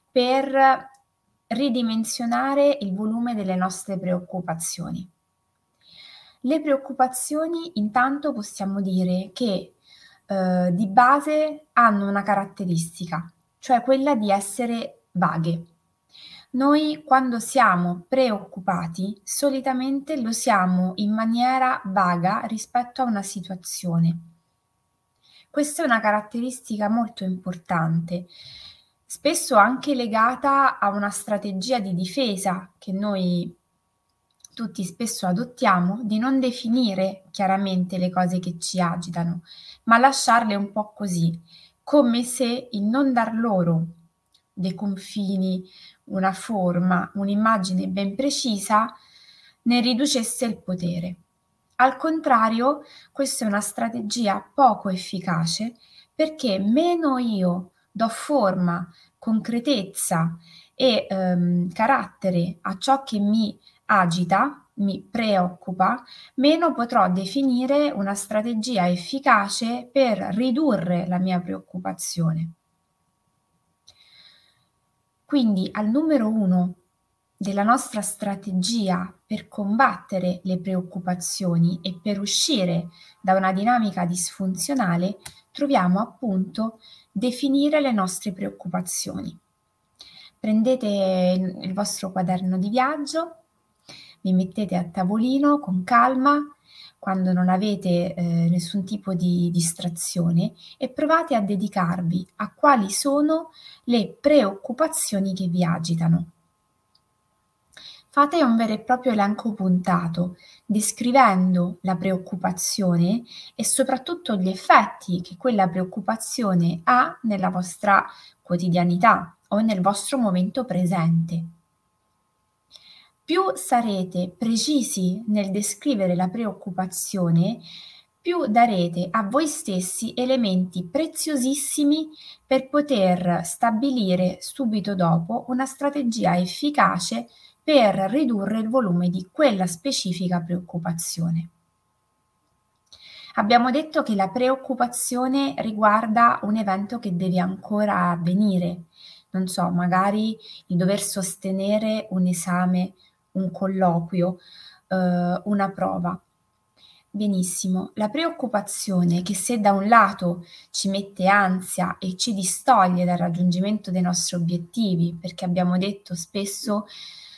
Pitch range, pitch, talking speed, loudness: 180-240 Hz, 200 Hz, 100 wpm, -22 LUFS